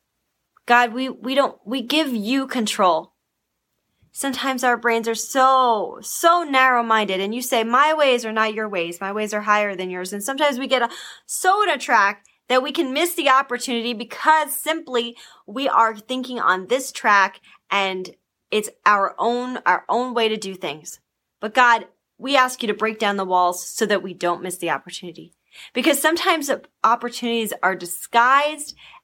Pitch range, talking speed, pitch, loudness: 205-265 Hz, 180 wpm, 235 Hz, -20 LUFS